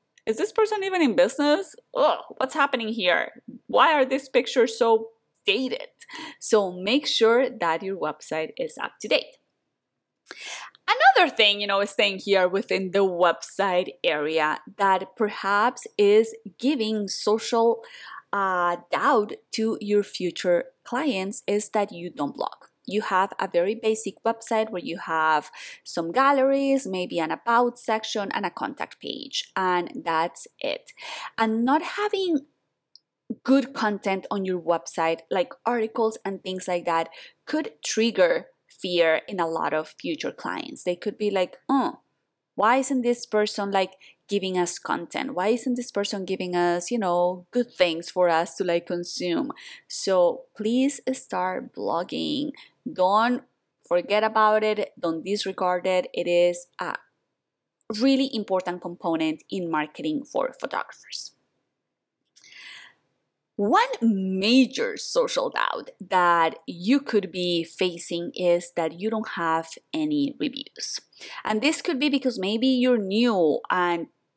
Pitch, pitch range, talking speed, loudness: 215 Hz, 180-265 Hz, 140 wpm, -24 LUFS